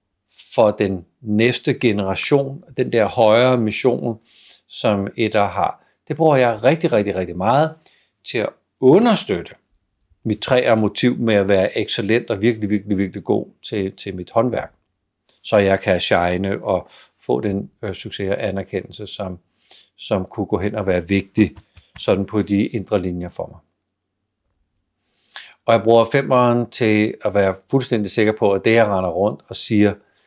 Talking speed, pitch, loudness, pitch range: 155 wpm, 105 Hz, -19 LUFS, 95-115 Hz